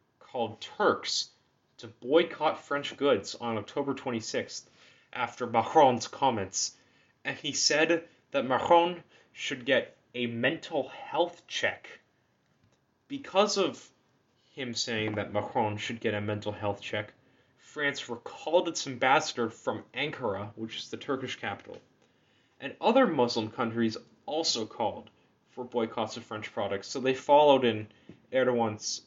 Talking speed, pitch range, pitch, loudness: 130 wpm, 110-145 Hz, 120 Hz, -29 LUFS